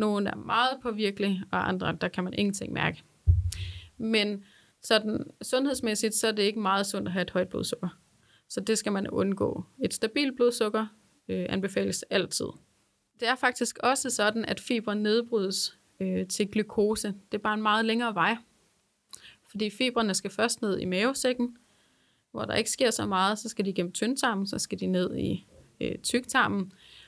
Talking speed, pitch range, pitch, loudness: 175 wpm, 190-230 Hz, 210 Hz, -28 LUFS